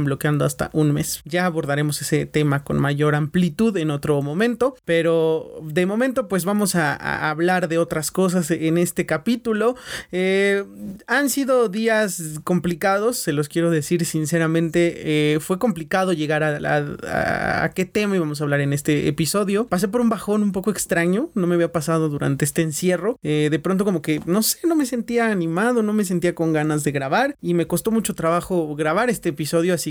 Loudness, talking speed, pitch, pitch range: -21 LUFS, 190 wpm, 175 Hz, 155-205 Hz